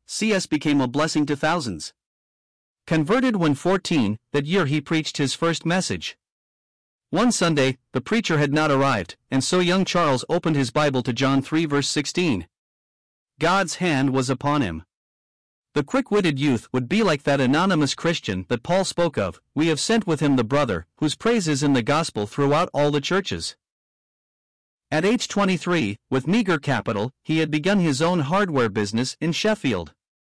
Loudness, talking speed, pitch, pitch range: -22 LUFS, 170 wpm, 150 Hz, 130-175 Hz